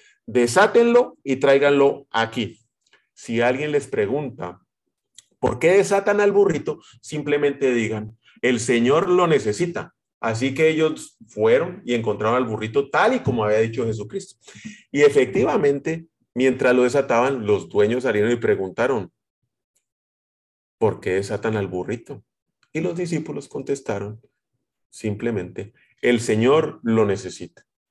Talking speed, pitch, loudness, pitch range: 125 wpm, 130 Hz, -21 LUFS, 115-160 Hz